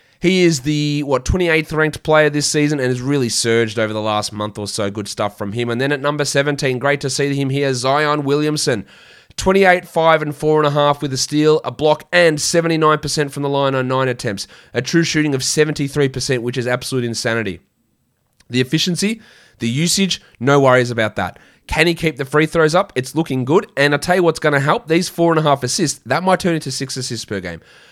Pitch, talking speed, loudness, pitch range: 145 Hz, 215 wpm, -17 LUFS, 125-155 Hz